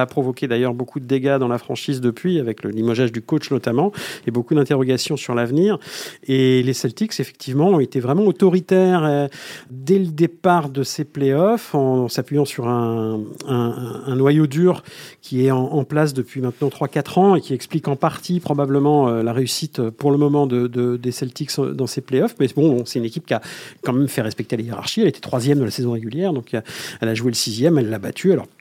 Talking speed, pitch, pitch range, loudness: 210 wpm, 135 Hz, 125-155 Hz, -19 LUFS